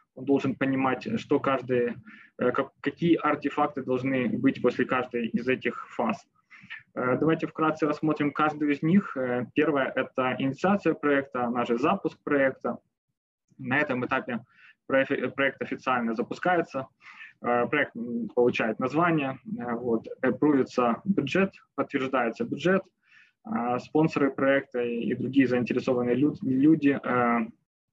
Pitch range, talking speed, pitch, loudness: 125-155 Hz, 100 wpm, 135 Hz, -27 LUFS